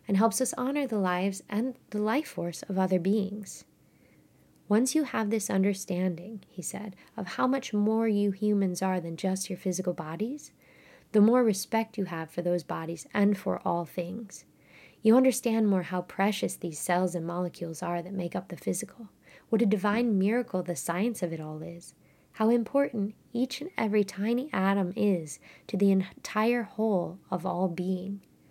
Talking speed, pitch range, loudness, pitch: 175 wpm, 180-220 Hz, -29 LUFS, 200 Hz